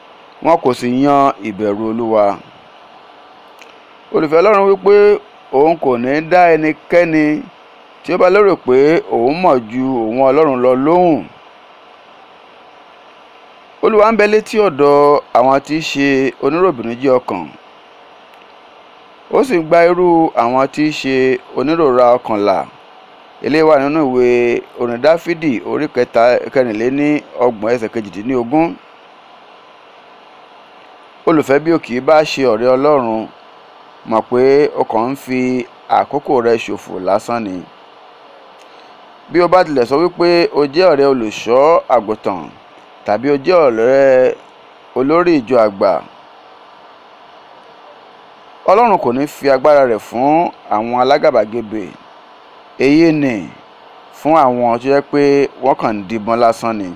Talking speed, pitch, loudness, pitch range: 130 wpm, 140 Hz, -13 LUFS, 120-160 Hz